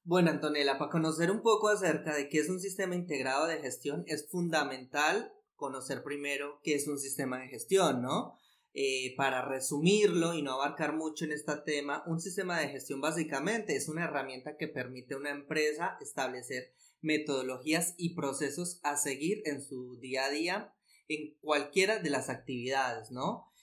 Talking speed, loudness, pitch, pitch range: 170 wpm, -33 LUFS, 150 Hz, 140-170 Hz